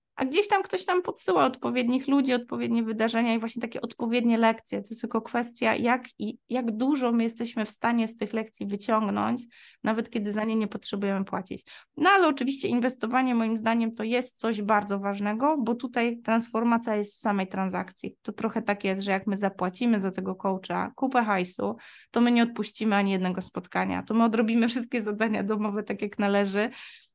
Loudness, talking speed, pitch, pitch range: -27 LUFS, 190 wpm, 225 Hz, 210-245 Hz